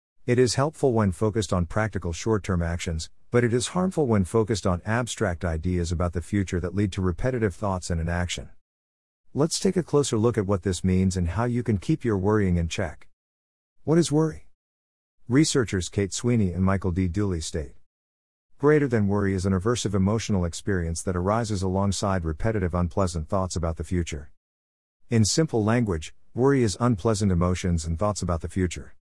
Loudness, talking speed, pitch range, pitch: -25 LUFS, 180 wpm, 85-115 Hz, 95 Hz